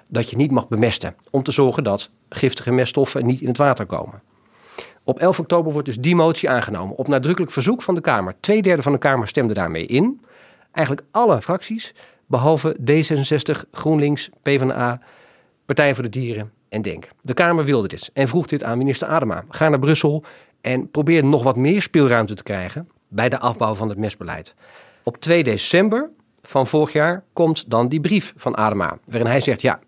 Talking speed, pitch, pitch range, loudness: 190 wpm, 140 Hz, 120-160 Hz, -19 LUFS